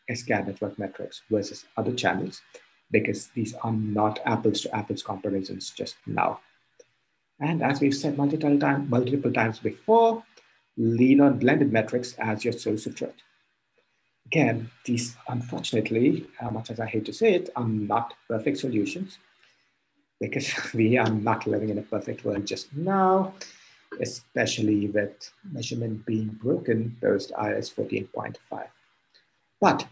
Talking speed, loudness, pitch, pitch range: 140 wpm, -26 LUFS, 115 Hz, 110-140 Hz